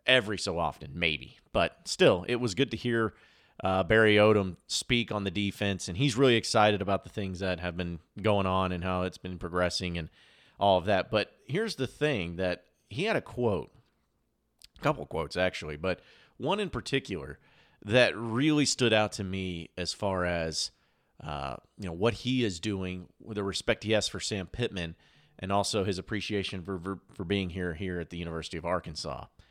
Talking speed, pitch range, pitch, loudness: 195 wpm, 90-110 Hz, 95 Hz, -30 LUFS